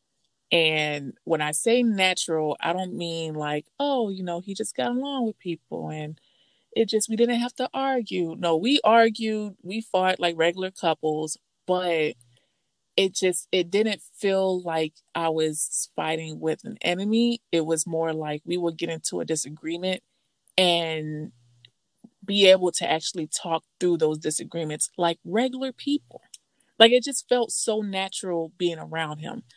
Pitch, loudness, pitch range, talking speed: 175 Hz, -25 LUFS, 160-220 Hz, 160 wpm